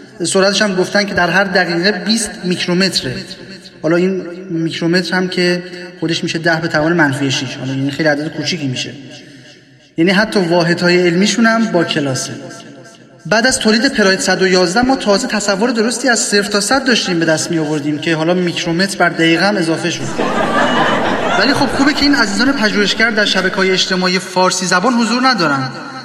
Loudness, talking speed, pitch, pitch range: -14 LUFS, 170 wpm, 185 Hz, 165-205 Hz